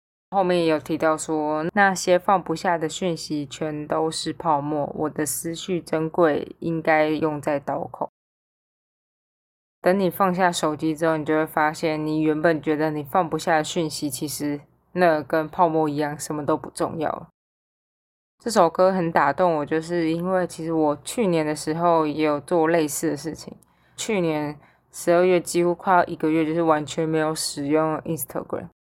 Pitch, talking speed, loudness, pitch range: 160 Hz, 260 characters per minute, -23 LUFS, 155-170 Hz